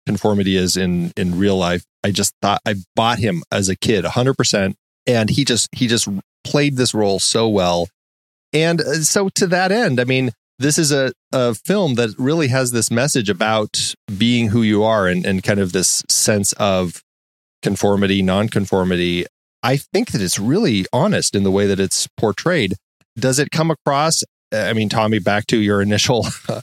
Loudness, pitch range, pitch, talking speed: -17 LUFS, 95-125 Hz, 105 Hz, 185 wpm